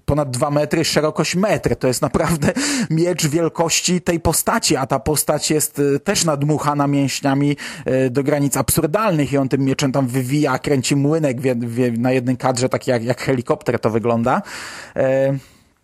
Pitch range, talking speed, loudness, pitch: 130-160 Hz, 160 wpm, -18 LUFS, 145 Hz